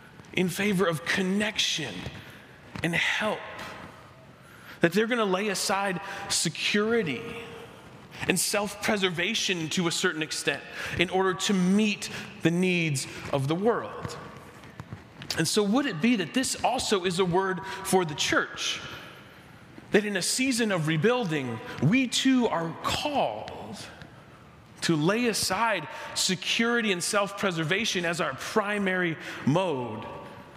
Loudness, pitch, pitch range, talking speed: -26 LUFS, 190 Hz, 175-210 Hz, 125 wpm